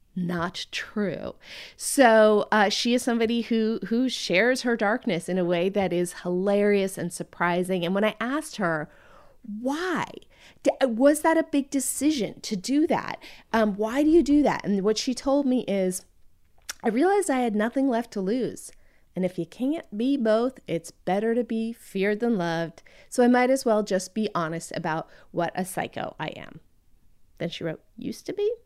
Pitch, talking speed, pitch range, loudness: 220 Hz, 185 wpm, 185-255 Hz, -25 LUFS